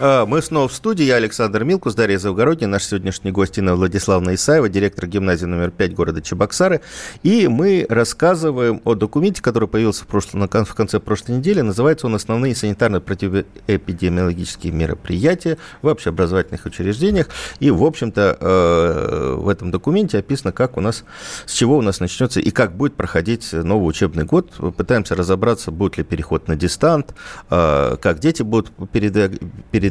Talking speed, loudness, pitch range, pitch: 160 wpm, -18 LUFS, 95-125 Hz, 105 Hz